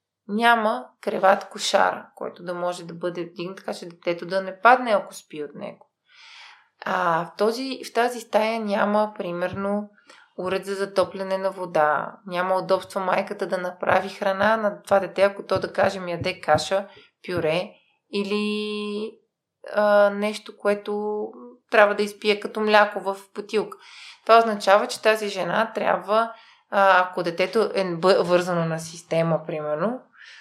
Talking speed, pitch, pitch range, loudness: 145 wpm, 195 Hz, 185-210 Hz, -23 LUFS